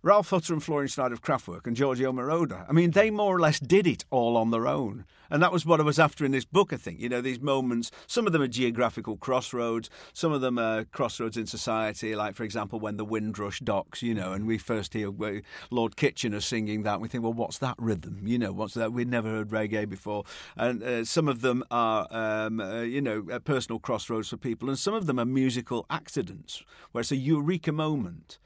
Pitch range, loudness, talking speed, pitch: 110-140 Hz, -28 LUFS, 235 wpm, 120 Hz